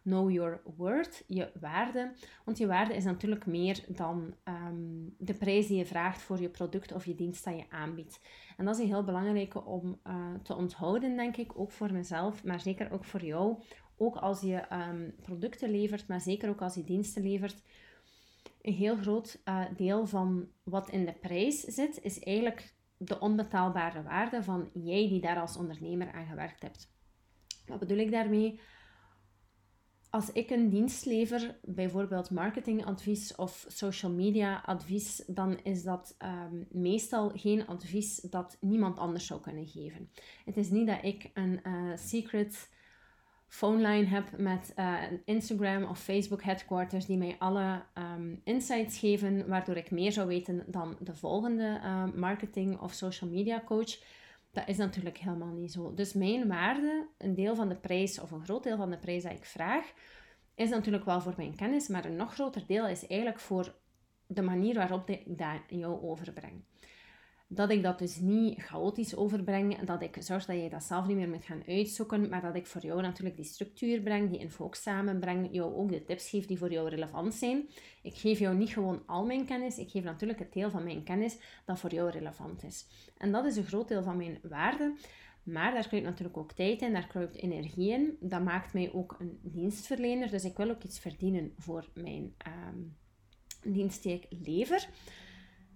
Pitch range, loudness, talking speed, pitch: 175-210 Hz, -34 LUFS, 185 wpm, 190 Hz